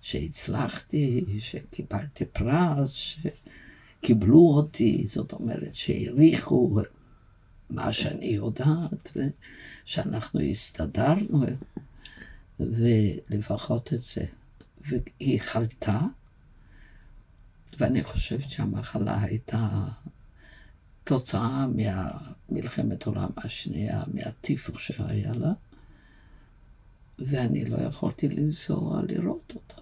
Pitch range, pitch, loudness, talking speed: 105-140 Hz, 115 Hz, -27 LUFS, 70 wpm